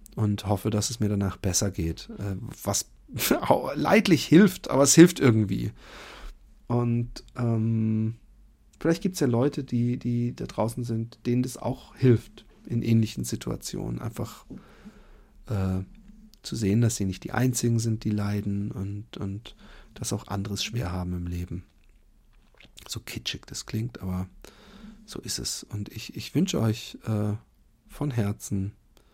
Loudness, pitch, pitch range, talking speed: -26 LUFS, 110 Hz, 100-125 Hz, 145 wpm